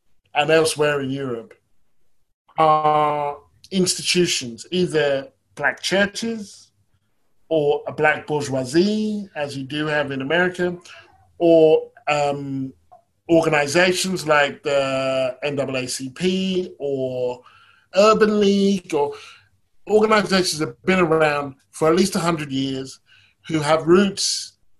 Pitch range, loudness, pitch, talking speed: 140-185 Hz, -20 LUFS, 155 Hz, 105 wpm